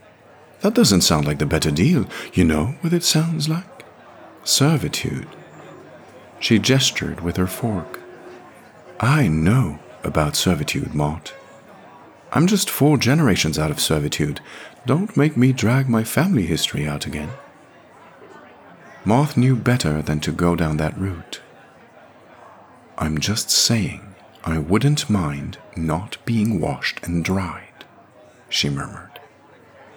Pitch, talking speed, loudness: 95 Hz, 125 wpm, -20 LUFS